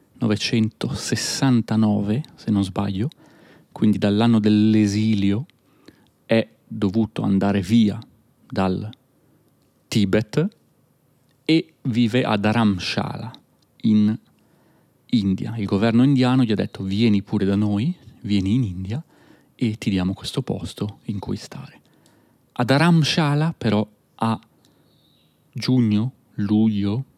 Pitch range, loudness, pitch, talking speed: 105-130 Hz, -21 LUFS, 110 Hz, 100 wpm